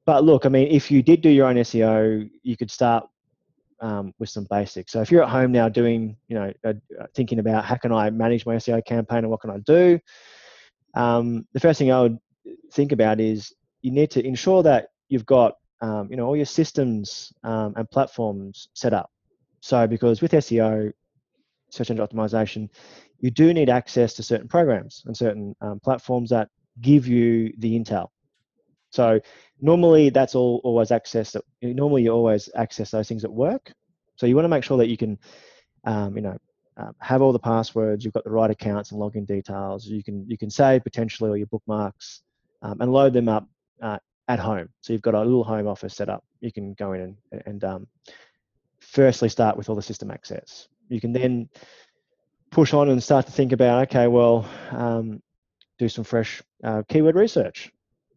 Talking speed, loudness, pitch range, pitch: 195 wpm, -21 LUFS, 110-130 Hz, 115 Hz